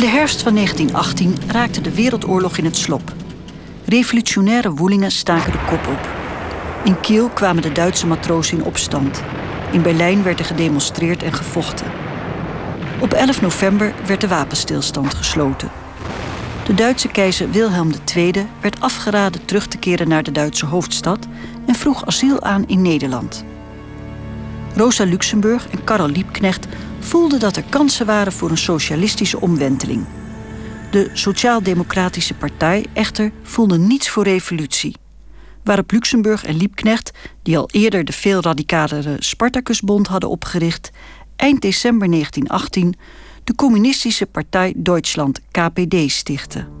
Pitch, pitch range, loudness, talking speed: 190 Hz, 165-220 Hz, -17 LUFS, 130 wpm